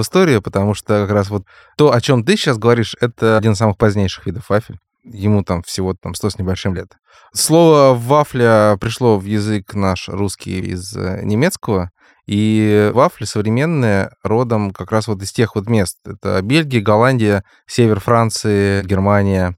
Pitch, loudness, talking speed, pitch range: 105 Hz, -15 LUFS, 160 wpm, 100-120 Hz